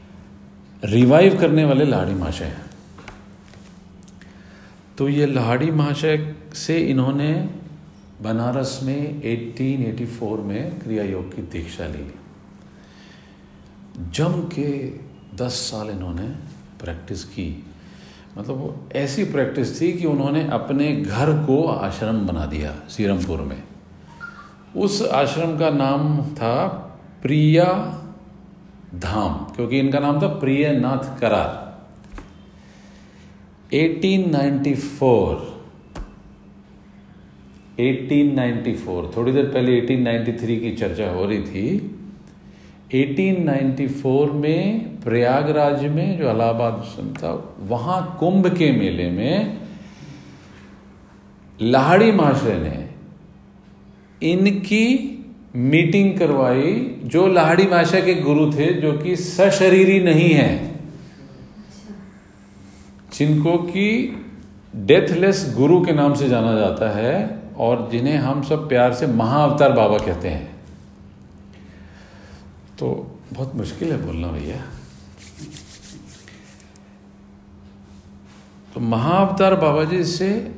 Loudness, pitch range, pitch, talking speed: -19 LUFS, 100-160 Hz, 135 Hz, 95 wpm